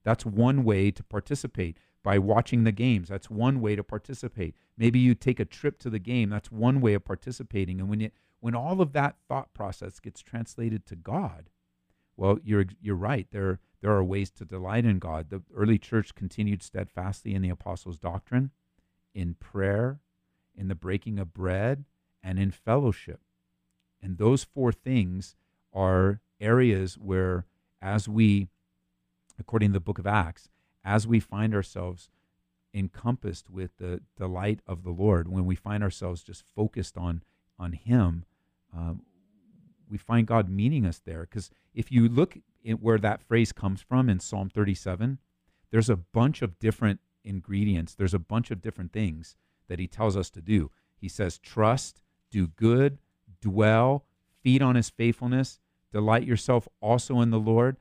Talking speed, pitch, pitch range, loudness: 165 wpm, 105 Hz, 95-115 Hz, -28 LUFS